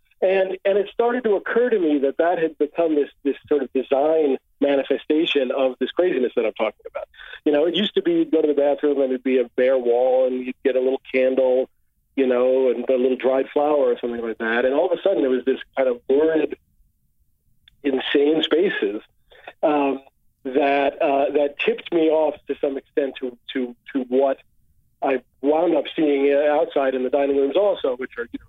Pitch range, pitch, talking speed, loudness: 130-165 Hz, 140 Hz, 210 wpm, -21 LUFS